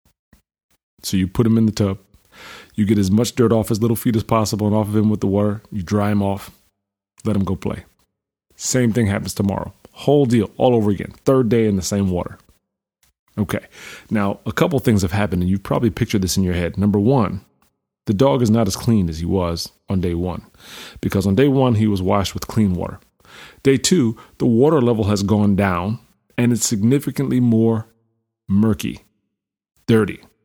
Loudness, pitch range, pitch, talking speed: -19 LUFS, 100-115 Hz, 105 Hz, 200 wpm